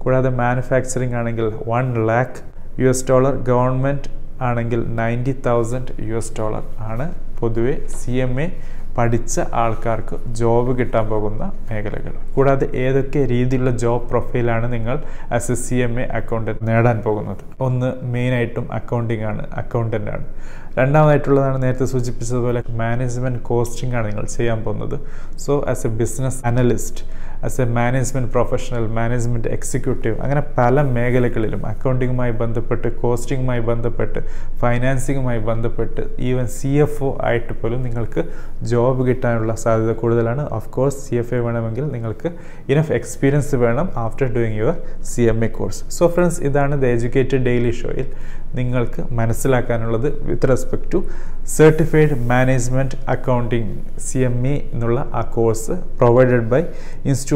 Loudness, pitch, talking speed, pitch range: -20 LUFS, 120 Hz, 130 wpm, 115-130 Hz